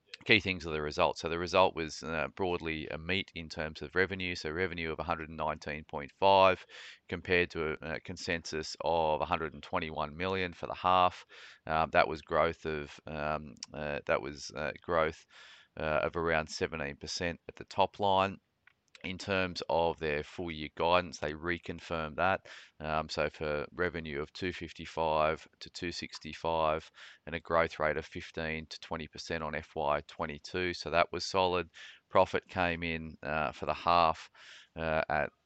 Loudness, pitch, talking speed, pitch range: -33 LUFS, 80 Hz, 155 wpm, 75-90 Hz